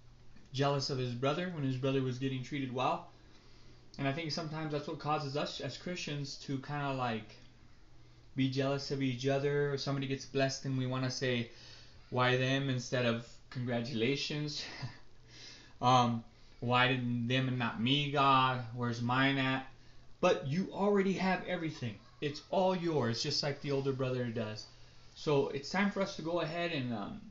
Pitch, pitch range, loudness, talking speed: 135 Hz, 125-145 Hz, -34 LUFS, 175 wpm